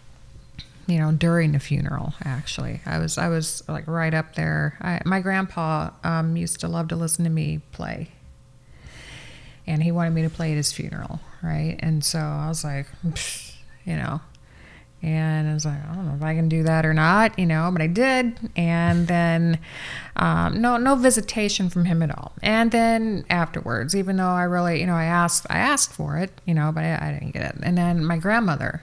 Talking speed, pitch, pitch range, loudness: 205 wpm, 165 Hz, 155-175 Hz, -23 LUFS